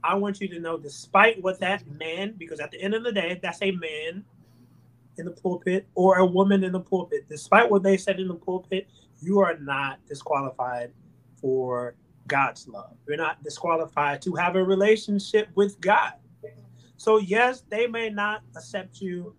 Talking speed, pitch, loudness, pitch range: 180 wpm, 185 Hz, -25 LUFS, 150-200 Hz